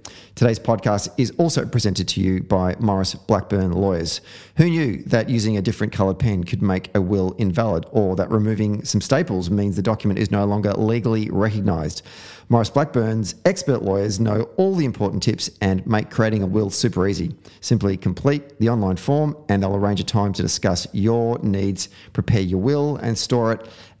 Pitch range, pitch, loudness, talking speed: 95-115 Hz, 105 Hz, -21 LUFS, 185 wpm